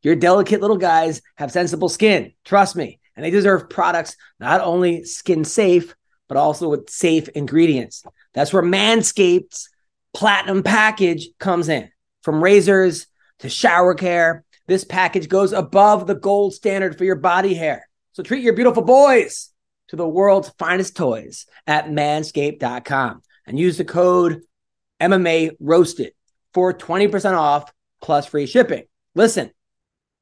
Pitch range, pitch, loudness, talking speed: 165-195 Hz, 180 Hz, -17 LUFS, 140 wpm